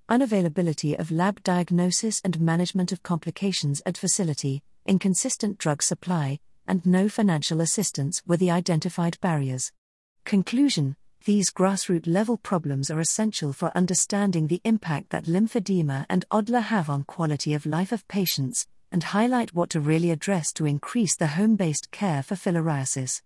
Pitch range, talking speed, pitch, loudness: 160-200 Hz, 145 wpm, 180 Hz, -25 LUFS